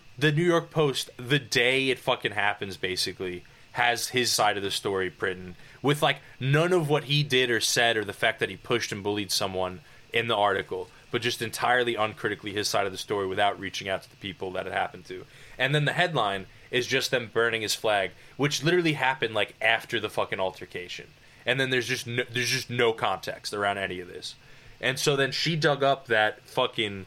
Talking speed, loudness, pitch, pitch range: 215 wpm, -26 LUFS, 120 Hz, 105-140 Hz